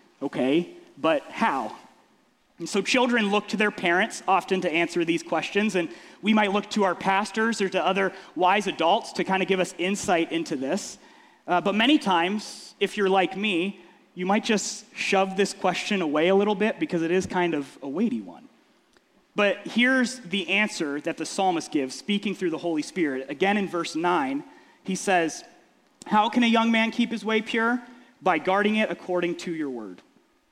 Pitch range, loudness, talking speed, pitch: 175-220 Hz, -25 LUFS, 190 wpm, 195 Hz